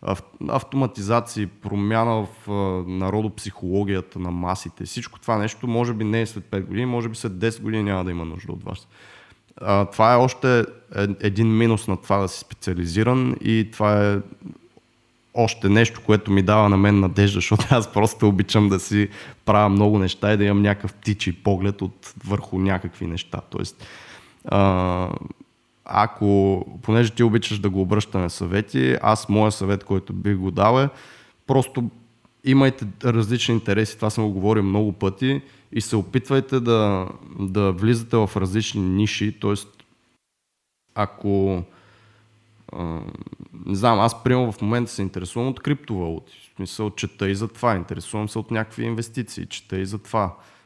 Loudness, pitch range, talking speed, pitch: -22 LUFS, 95-115 Hz, 155 wpm, 105 Hz